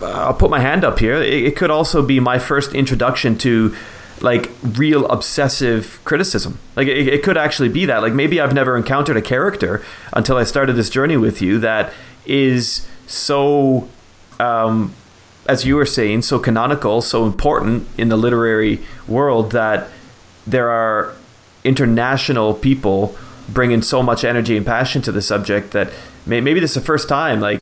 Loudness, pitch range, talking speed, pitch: -16 LUFS, 110-135 Hz, 165 wpm, 125 Hz